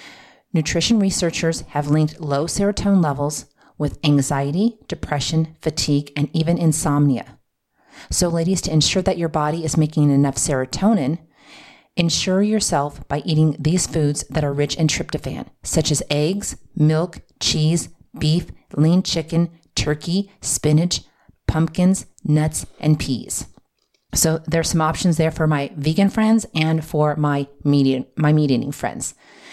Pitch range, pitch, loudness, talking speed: 145-170 Hz, 155 Hz, -20 LUFS, 135 wpm